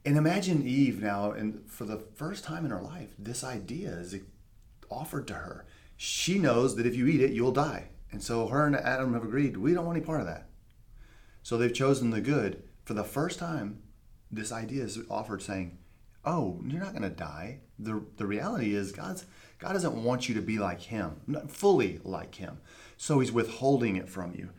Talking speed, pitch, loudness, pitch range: 205 wpm, 115 Hz, -31 LUFS, 100-135 Hz